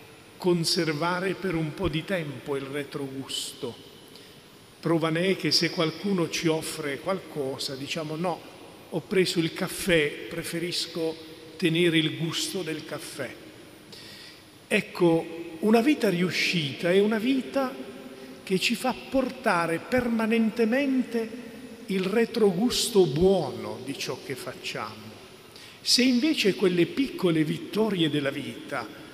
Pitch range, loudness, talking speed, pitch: 160-210 Hz, -26 LUFS, 115 wpm, 175 Hz